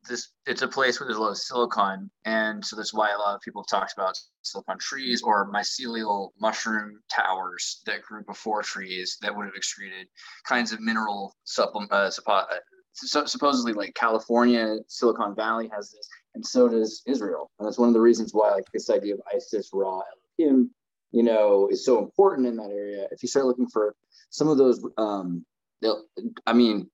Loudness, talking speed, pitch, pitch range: -25 LUFS, 195 wpm, 115 Hz, 105-140 Hz